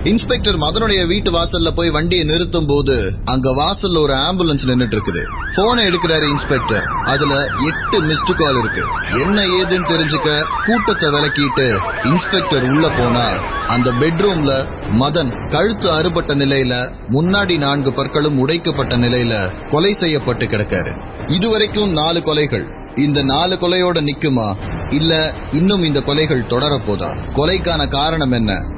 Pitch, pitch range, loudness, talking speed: 150 Hz, 125-175 Hz, -15 LUFS, 120 wpm